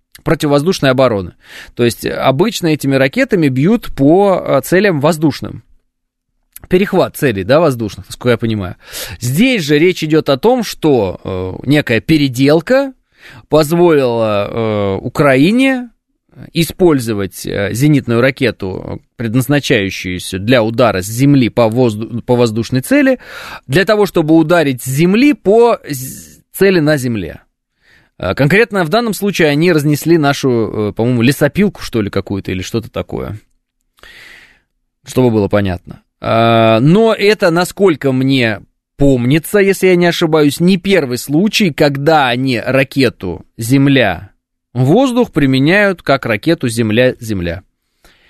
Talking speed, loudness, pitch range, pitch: 115 wpm, -12 LUFS, 115-175 Hz, 135 Hz